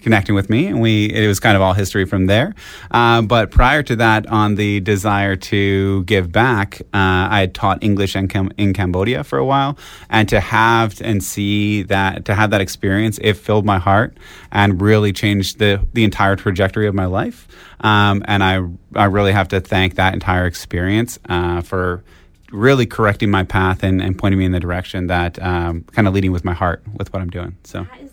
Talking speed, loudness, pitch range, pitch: 205 wpm, -16 LUFS, 95-105 Hz, 100 Hz